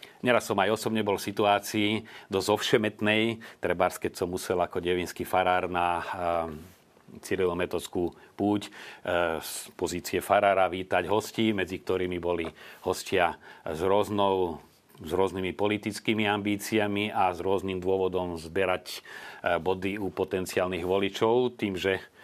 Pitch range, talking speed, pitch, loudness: 90-105 Hz, 120 wpm, 95 Hz, -28 LUFS